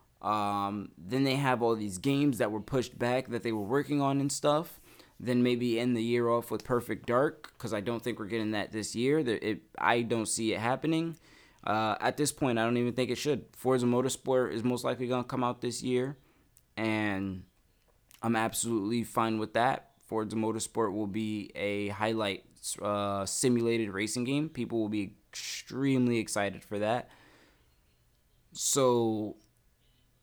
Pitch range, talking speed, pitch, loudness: 110-125 Hz, 175 wpm, 115 Hz, -31 LUFS